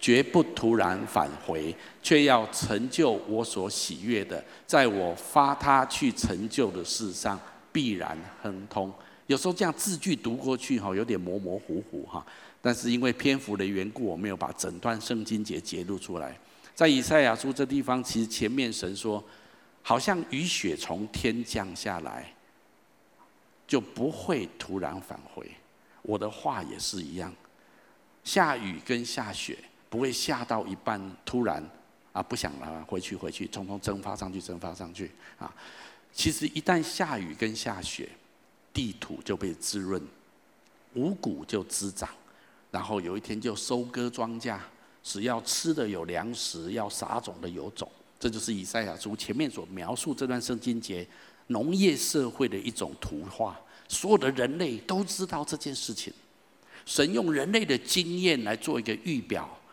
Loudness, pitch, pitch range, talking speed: -30 LUFS, 115 Hz, 100-130 Hz, 235 characters per minute